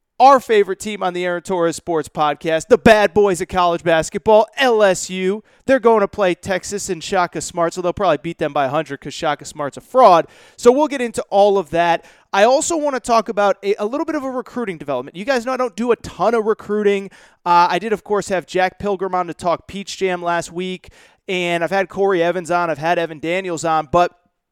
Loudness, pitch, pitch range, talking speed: -17 LUFS, 185 Hz, 170-210 Hz, 230 wpm